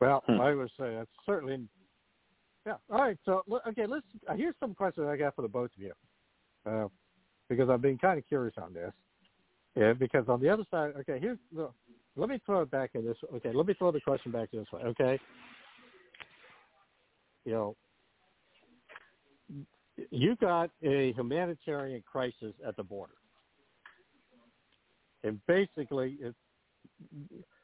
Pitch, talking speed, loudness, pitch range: 140 Hz, 150 wpm, -33 LUFS, 120-175 Hz